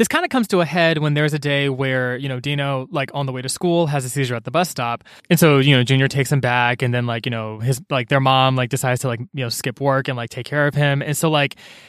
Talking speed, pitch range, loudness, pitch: 315 wpm, 125-145 Hz, -19 LUFS, 135 Hz